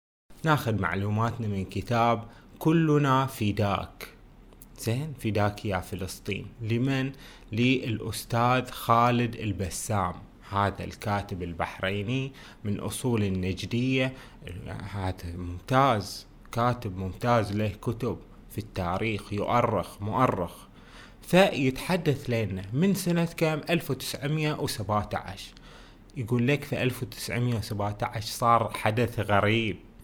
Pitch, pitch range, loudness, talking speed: 110 Hz, 100-130 Hz, -28 LUFS, 90 wpm